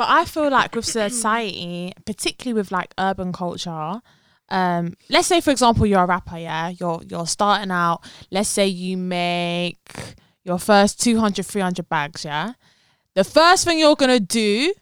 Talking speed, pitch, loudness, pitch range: 165 wpm, 190 Hz, -20 LUFS, 175-230 Hz